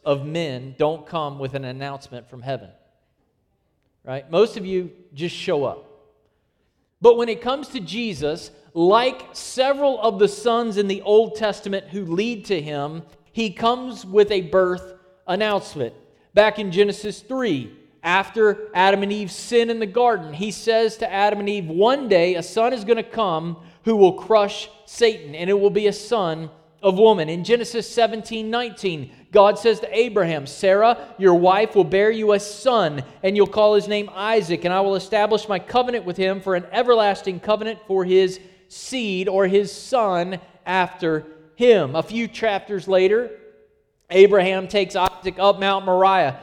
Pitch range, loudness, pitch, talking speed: 180-220 Hz, -20 LUFS, 200 Hz, 170 wpm